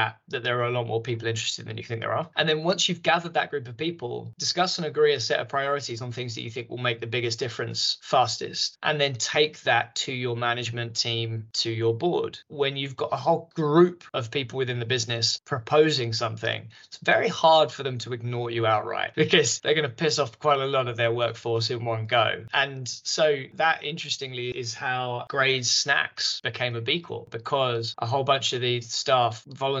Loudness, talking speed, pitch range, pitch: -25 LUFS, 215 wpm, 120-150 Hz, 125 Hz